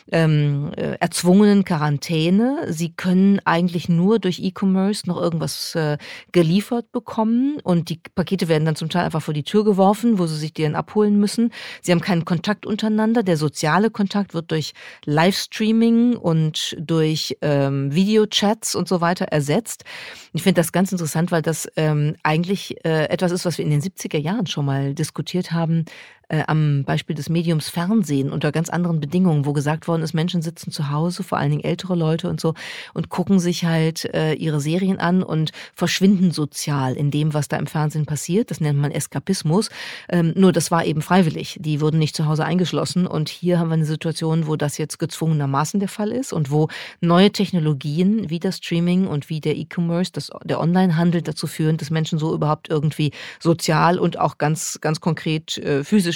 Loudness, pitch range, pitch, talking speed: -20 LUFS, 155-185 Hz, 170 Hz, 185 wpm